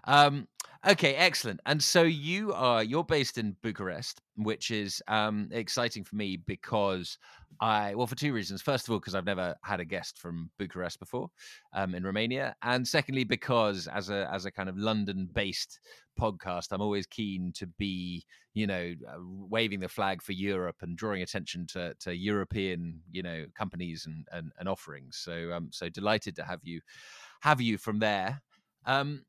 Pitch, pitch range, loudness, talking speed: 100 Hz, 90-115 Hz, -31 LUFS, 180 wpm